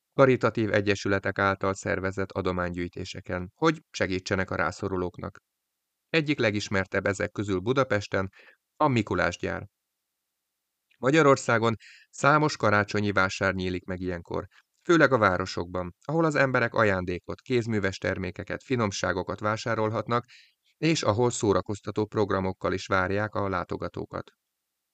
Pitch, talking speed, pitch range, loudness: 100 Hz, 100 wpm, 95-115 Hz, -27 LUFS